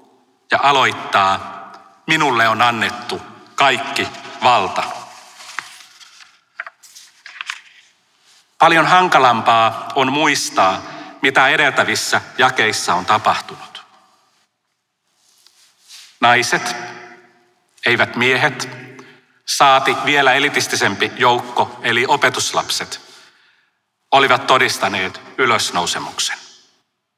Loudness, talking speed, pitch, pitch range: -15 LUFS, 60 wpm, 120 Hz, 115-130 Hz